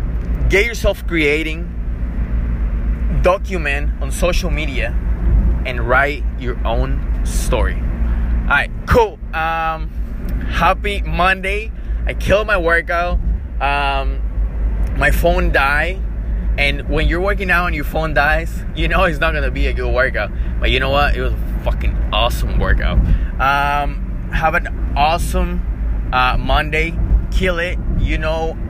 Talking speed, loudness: 135 wpm, -18 LUFS